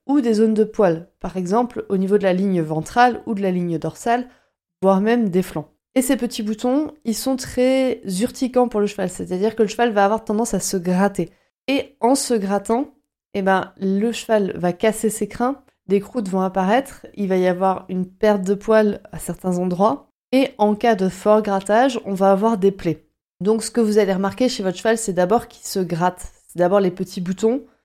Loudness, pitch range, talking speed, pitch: -20 LUFS, 190-235 Hz, 215 wpm, 210 Hz